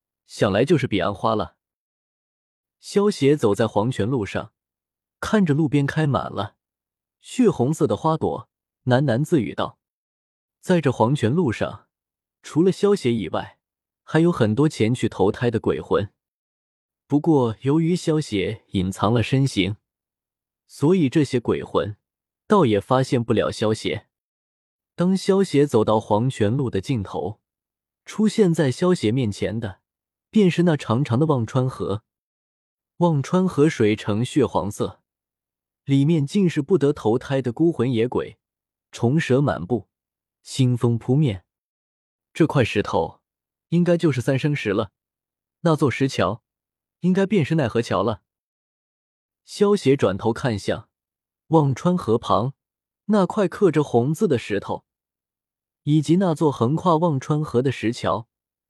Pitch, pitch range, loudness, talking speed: 130 Hz, 105-160 Hz, -21 LUFS, 200 characters per minute